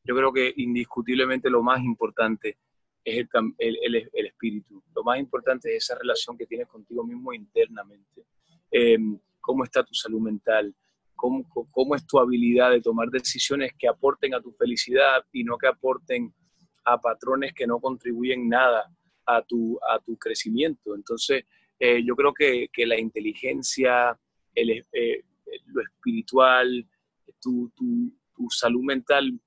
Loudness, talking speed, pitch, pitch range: -24 LUFS, 155 wpm, 130 Hz, 120-185 Hz